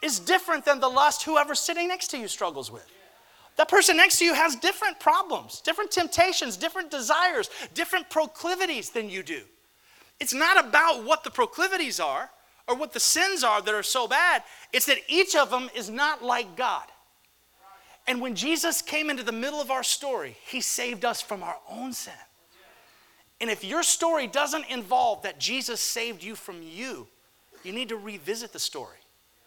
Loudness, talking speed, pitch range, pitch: -25 LUFS, 180 wpm, 240-345 Hz, 295 Hz